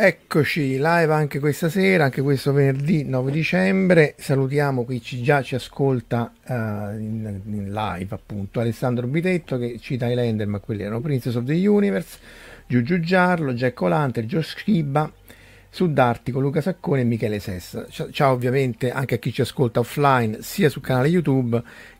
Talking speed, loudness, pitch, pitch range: 160 wpm, -22 LUFS, 135 Hz, 120-155 Hz